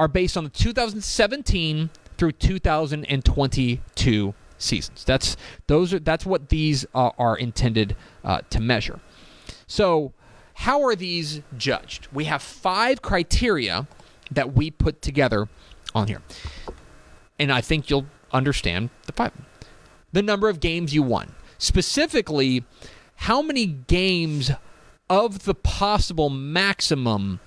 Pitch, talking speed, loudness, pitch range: 150 Hz, 120 wpm, -23 LUFS, 125-180 Hz